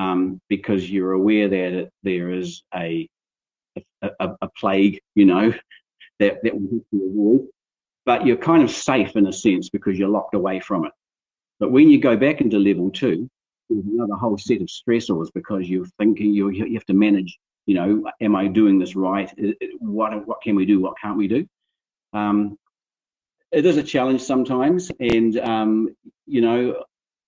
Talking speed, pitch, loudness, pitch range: 185 wpm, 105 Hz, -20 LUFS, 95-115 Hz